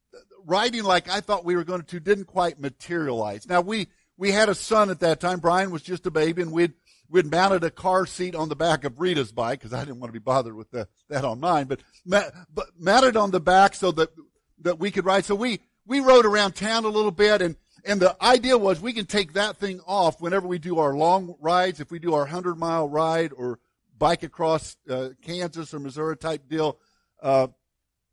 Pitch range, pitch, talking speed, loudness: 160-200 Hz, 180 Hz, 225 wpm, -23 LUFS